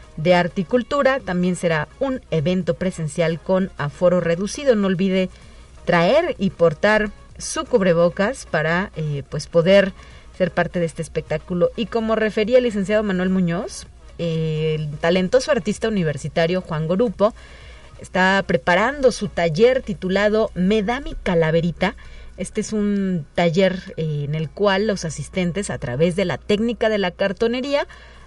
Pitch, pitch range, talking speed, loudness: 185 Hz, 170-215 Hz, 145 wpm, -20 LUFS